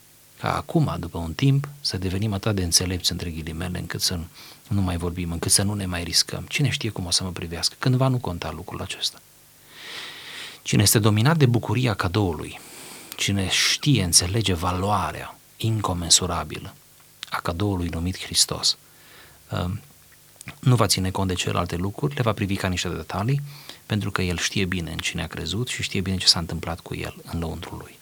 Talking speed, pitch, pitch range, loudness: 180 wpm, 95 Hz, 85-110 Hz, -23 LUFS